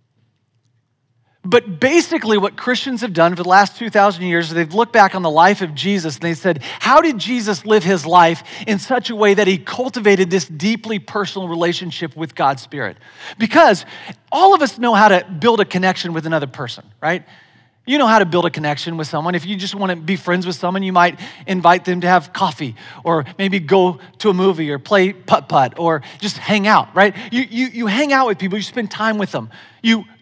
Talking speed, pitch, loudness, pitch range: 215 wpm, 190 Hz, -16 LUFS, 170-215 Hz